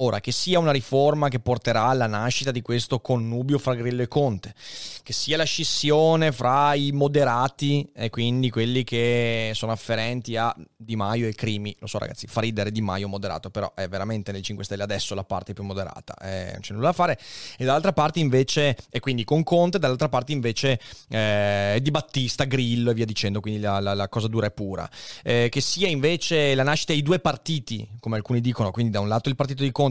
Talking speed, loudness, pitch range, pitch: 215 wpm, -24 LUFS, 105-140 Hz, 120 Hz